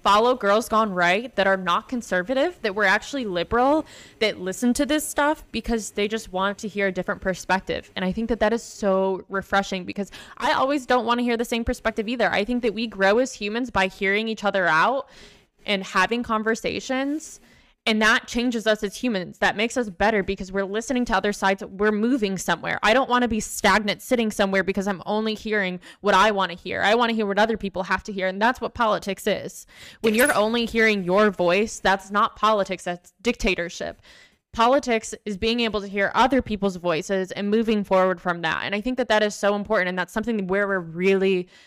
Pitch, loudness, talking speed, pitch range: 210 Hz, -23 LUFS, 215 wpm, 195-230 Hz